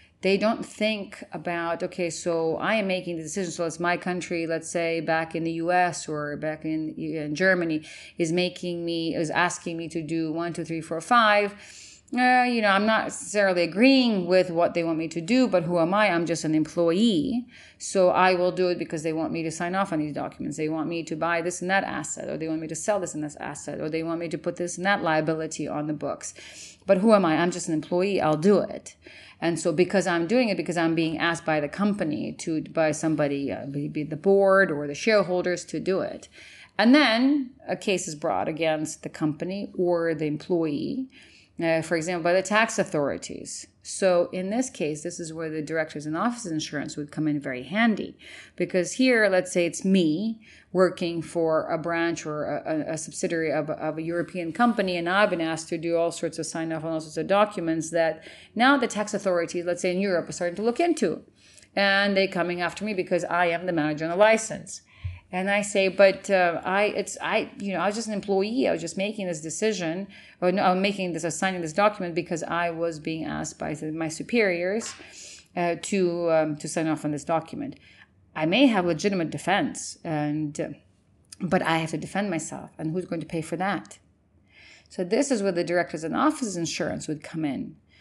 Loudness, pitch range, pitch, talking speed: -25 LUFS, 160-195 Hz, 175 Hz, 220 wpm